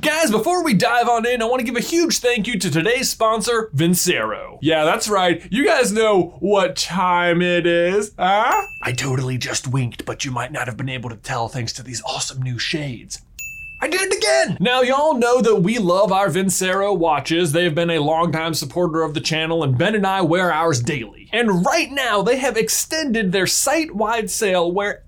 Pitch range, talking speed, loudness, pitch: 160-225 Hz, 205 wpm, -18 LUFS, 180 Hz